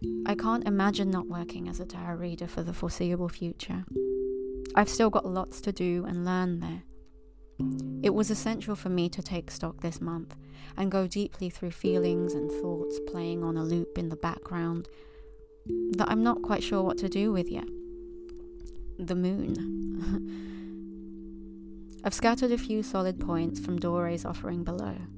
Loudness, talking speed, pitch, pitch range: -31 LUFS, 160 wpm, 175 Hz, 130-190 Hz